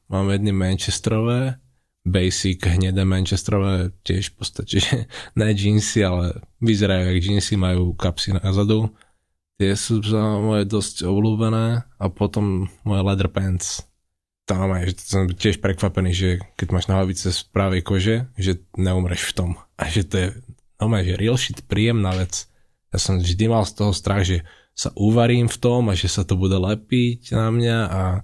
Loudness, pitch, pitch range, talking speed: -21 LUFS, 95 Hz, 90-110 Hz, 165 wpm